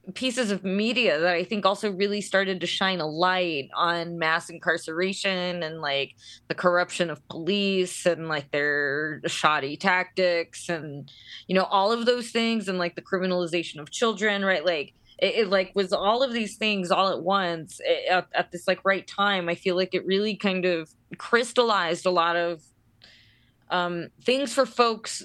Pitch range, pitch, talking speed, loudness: 165-200 Hz, 180 Hz, 180 wpm, -25 LUFS